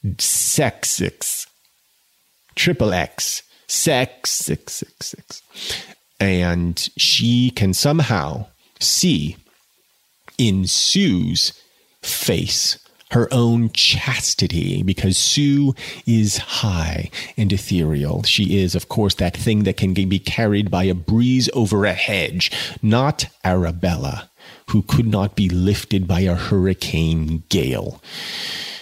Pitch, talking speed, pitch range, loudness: 100 Hz, 110 wpm, 90-115 Hz, -18 LUFS